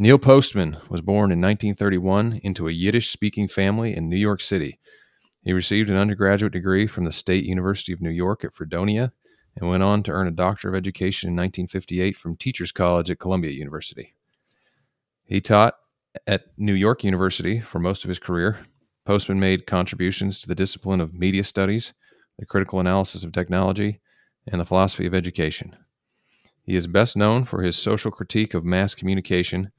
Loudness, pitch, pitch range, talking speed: -22 LUFS, 95 Hz, 90-105 Hz, 175 wpm